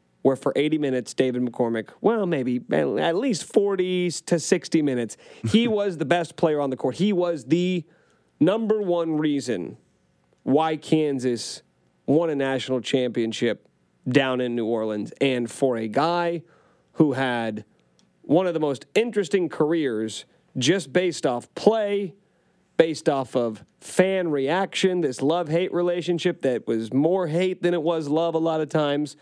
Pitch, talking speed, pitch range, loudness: 155 Hz, 155 wpm, 125-175 Hz, -24 LUFS